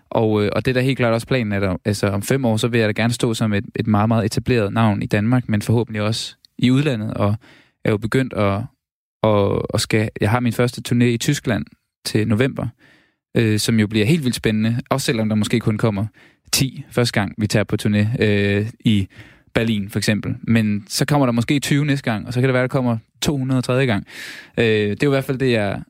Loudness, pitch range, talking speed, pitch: -19 LUFS, 105-125 Hz, 240 wpm, 115 Hz